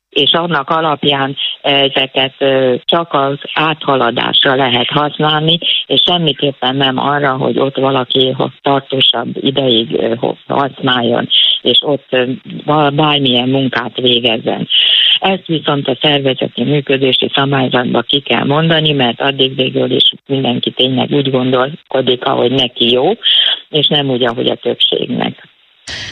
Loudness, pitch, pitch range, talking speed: -12 LUFS, 135 Hz, 130-145 Hz, 115 wpm